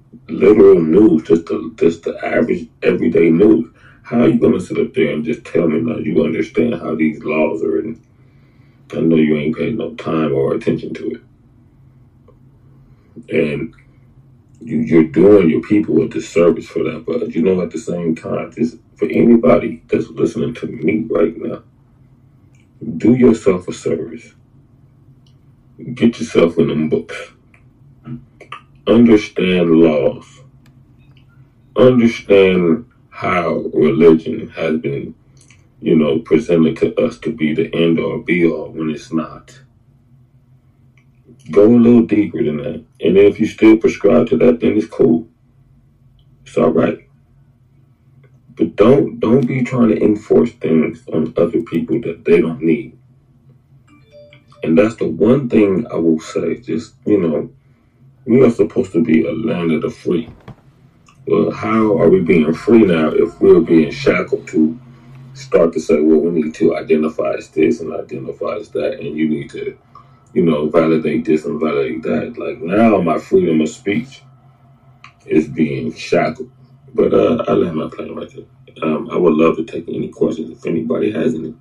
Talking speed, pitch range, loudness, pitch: 160 wpm, 85-130 Hz, -15 LUFS, 125 Hz